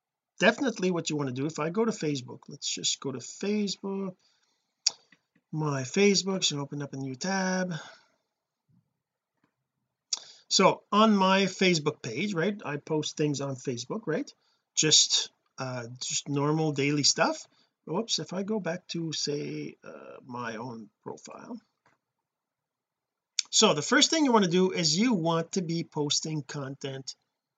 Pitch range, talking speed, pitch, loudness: 145-195 Hz, 150 wpm, 160 Hz, -27 LUFS